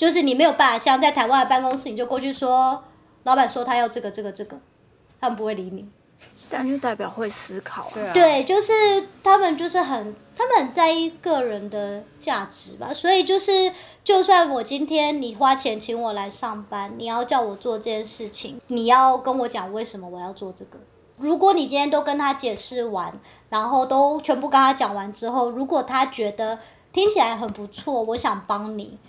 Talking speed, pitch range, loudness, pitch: 285 characters per minute, 220-295 Hz, -21 LUFS, 255 Hz